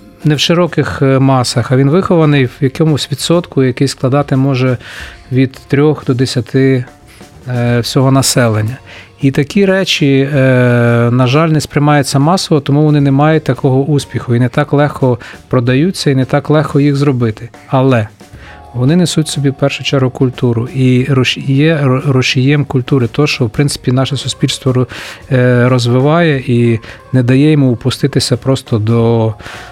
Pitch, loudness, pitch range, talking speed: 135 Hz, -11 LUFS, 125-145 Hz, 145 wpm